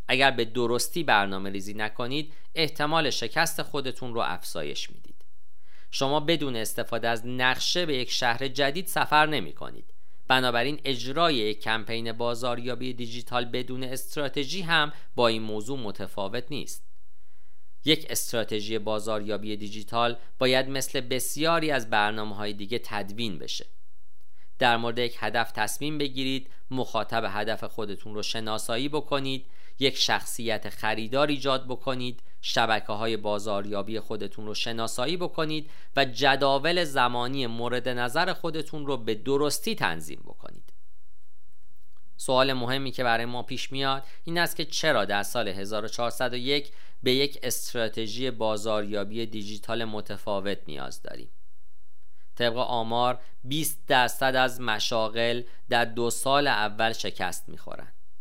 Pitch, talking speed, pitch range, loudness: 120 Hz, 125 wpm, 110-135 Hz, -28 LUFS